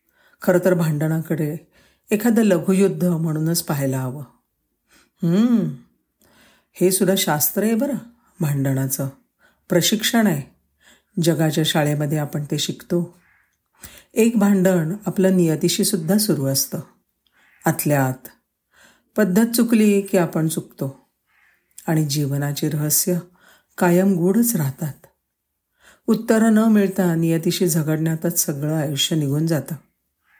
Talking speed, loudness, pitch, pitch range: 105 wpm, -20 LUFS, 175 Hz, 155-195 Hz